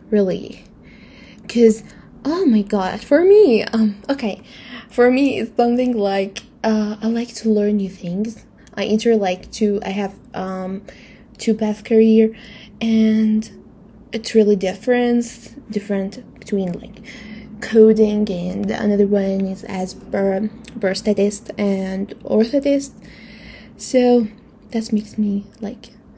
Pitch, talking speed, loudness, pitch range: 215 Hz, 120 wpm, -18 LUFS, 205-230 Hz